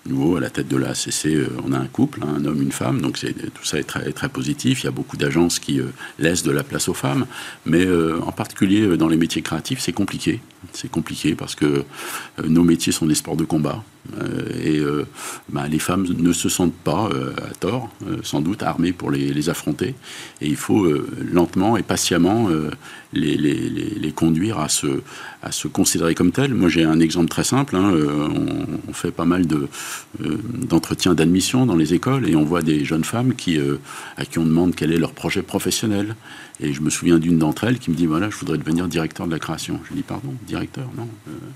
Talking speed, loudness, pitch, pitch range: 235 wpm, -20 LUFS, 80 Hz, 75-90 Hz